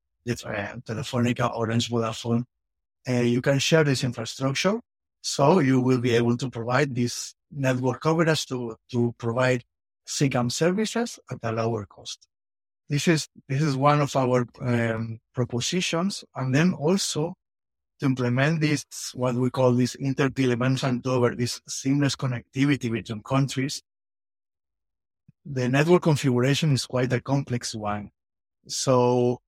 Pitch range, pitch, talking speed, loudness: 115-140 Hz, 125 Hz, 130 wpm, -25 LUFS